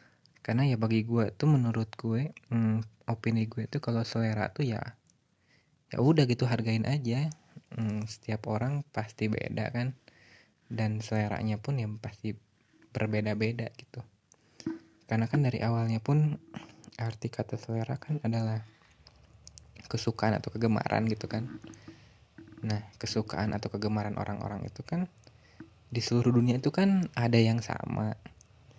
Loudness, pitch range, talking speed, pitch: -31 LUFS, 110-125 Hz, 130 wpm, 115 Hz